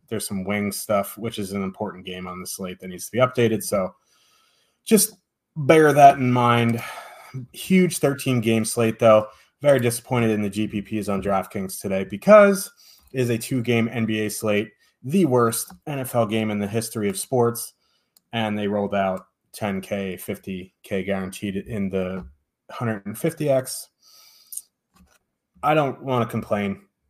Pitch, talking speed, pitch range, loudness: 110 Hz, 150 wpm, 100-125 Hz, -22 LUFS